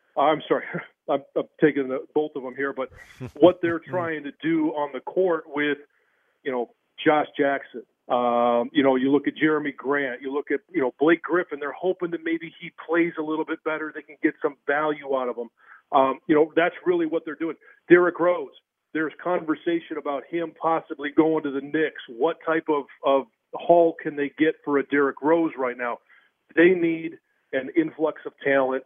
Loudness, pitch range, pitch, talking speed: -24 LUFS, 140-165 Hz, 155 Hz, 200 wpm